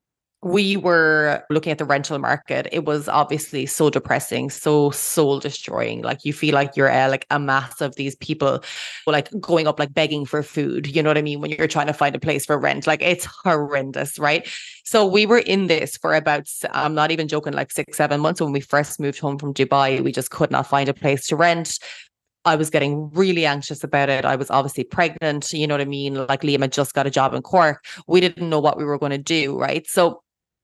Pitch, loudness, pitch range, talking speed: 150 Hz, -20 LUFS, 140-155 Hz, 235 wpm